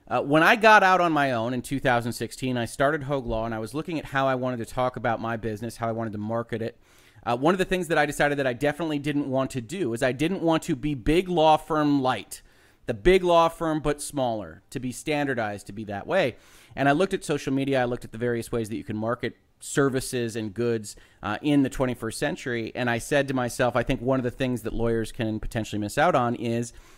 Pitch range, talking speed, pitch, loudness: 115-145 Hz, 255 wpm, 125 Hz, -25 LUFS